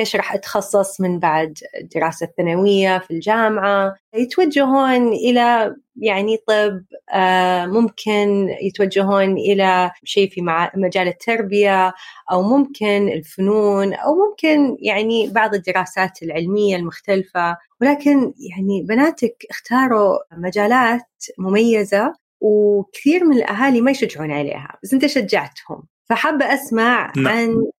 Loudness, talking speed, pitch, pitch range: -17 LUFS, 105 wpm, 205 Hz, 190-235 Hz